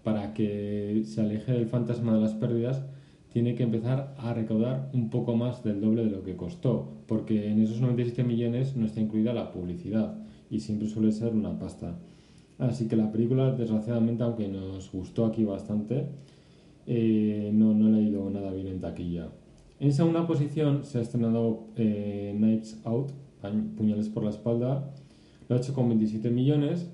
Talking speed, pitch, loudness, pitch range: 175 wpm, 115 Hz, -28 LUFS, 105-125 Hz